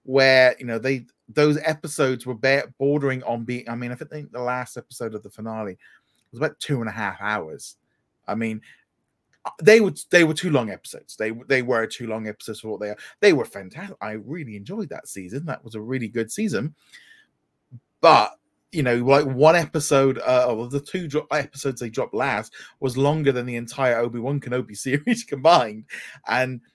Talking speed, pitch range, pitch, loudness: 195 wpm, 115-145 Hz, 130 Hz, -22 LUFS